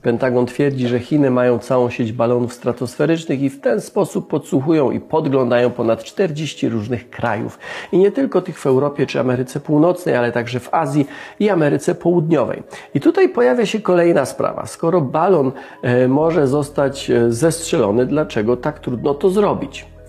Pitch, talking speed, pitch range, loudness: 140 Hz, 155 wpm, 125-165 Hz, -17 LUFS